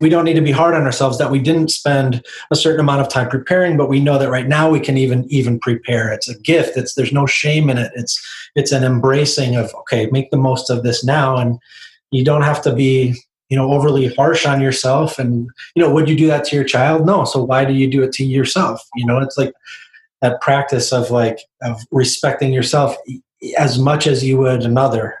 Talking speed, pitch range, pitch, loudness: 235 wpm, 130-145 Hz, 135 Hz, -15 LUFS